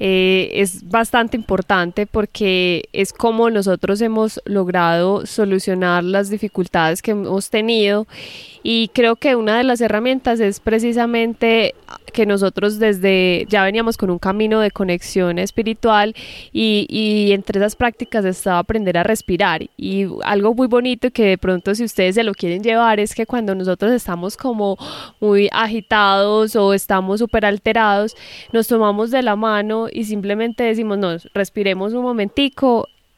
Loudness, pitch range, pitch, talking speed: -17 LUFS, 195-230 Hz, 210 Hz, 150 wpm